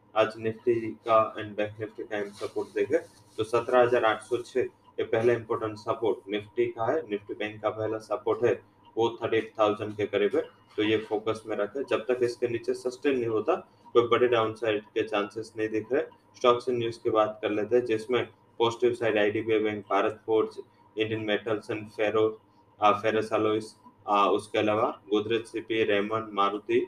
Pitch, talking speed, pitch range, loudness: 110 Hz, 185 wpm, 105-120 Hz, -28 LUFS